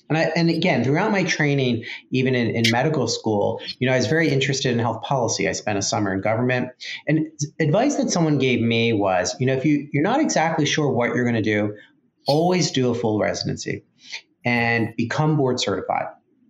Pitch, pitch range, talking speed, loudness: 130 Hz, 115-155 Hz, 205 wpm, -21 LUFS